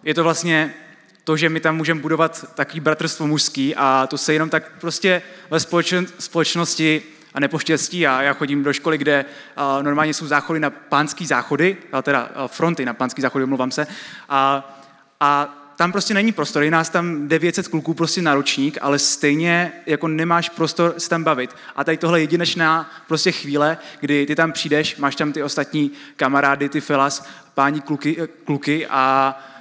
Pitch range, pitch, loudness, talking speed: 140-165 Hz, 155 Hz, -19 LUFS, 170 wpm